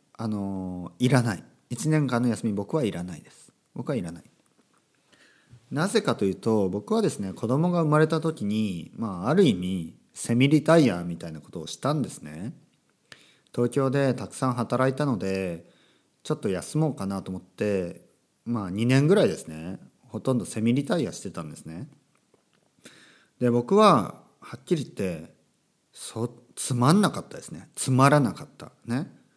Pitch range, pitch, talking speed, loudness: 95-140 Hz, 120 Hz, 310 characters per minute, -25 LUFS